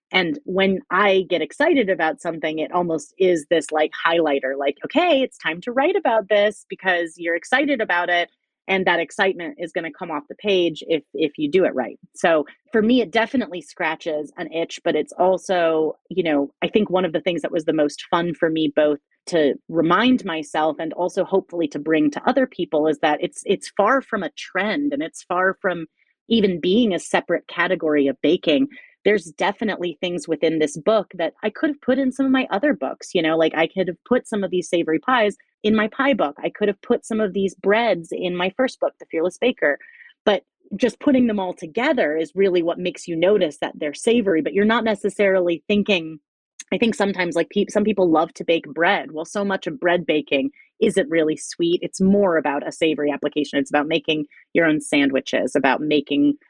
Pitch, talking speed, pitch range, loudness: 180 Hz, 215 wpm, 160-215 Hz, -21 LUFS